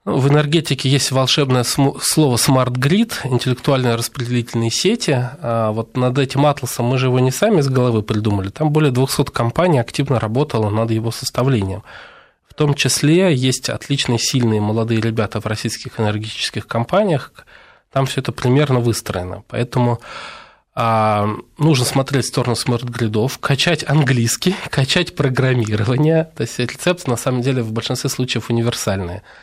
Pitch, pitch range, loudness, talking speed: 125 Hz, 115-140 Hz, -17 LUFS, 140 wpm